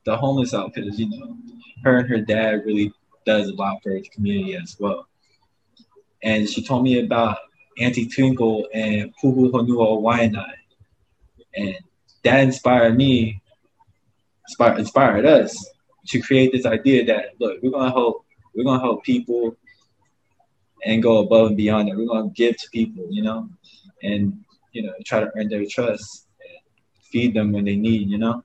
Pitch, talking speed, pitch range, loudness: 115 Hz, 165 wpm, 110-130 Hz, -20 LUFS